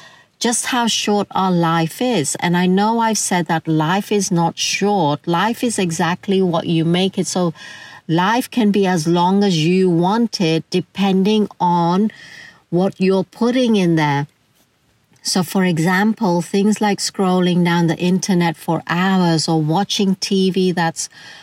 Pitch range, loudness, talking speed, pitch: 170-205 Hz, -17 LUFS, 155 wpm, 185 Hz